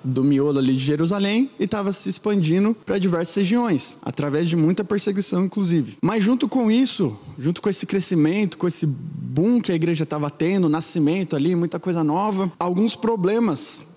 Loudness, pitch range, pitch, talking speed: -21 LUFS, 160-205 Hz, 175 Hz, 170 wpm